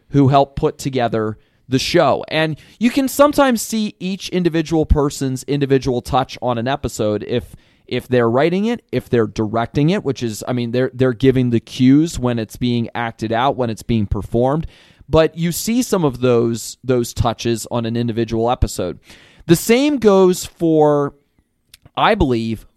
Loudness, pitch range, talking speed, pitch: -17 LUFS, 115-155 Hz, 170 wpm, 130 Hz